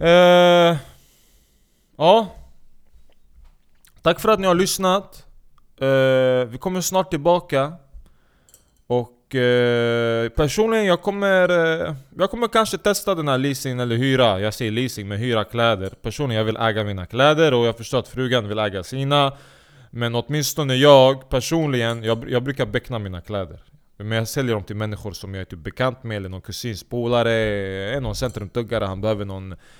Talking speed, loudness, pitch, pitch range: 160 wpm, -20 LUFS, 125 Hz, 105-145 Hz